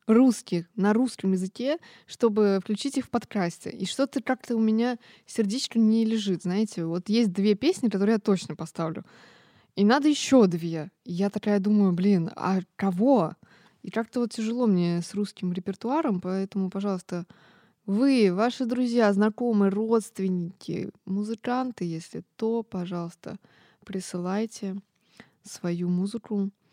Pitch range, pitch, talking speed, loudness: 185-230 Hz, 205 Hz, 130 wpm, -26 LUFS